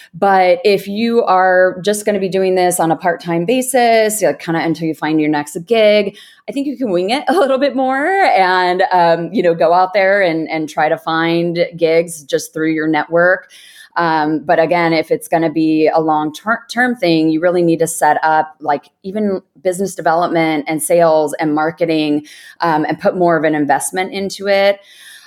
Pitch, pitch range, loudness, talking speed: 175 Hz, 160-200 Hz, -14 LUFS, 200 wpm